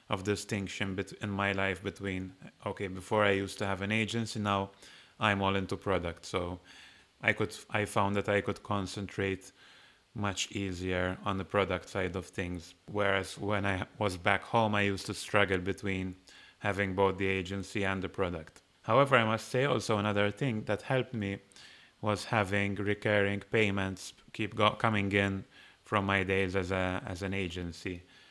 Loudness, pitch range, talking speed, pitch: -32 LUFS, 95-105 Hz, 165 wpm, 100 Hz